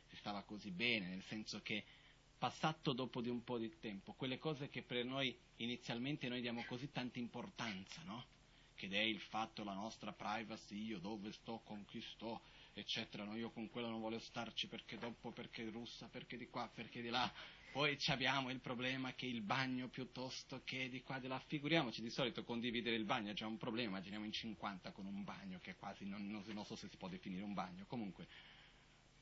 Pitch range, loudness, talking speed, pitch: 110-130 Hz, -45 LUFS, 205 wpm, 120 Hz